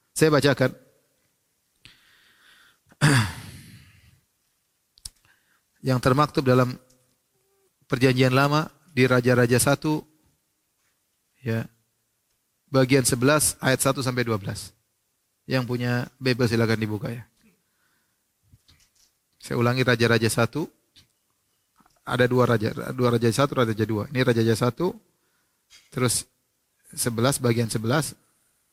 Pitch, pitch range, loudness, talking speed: 125 Hz, 115-135 Hz, -23 LUFS, 85 wpm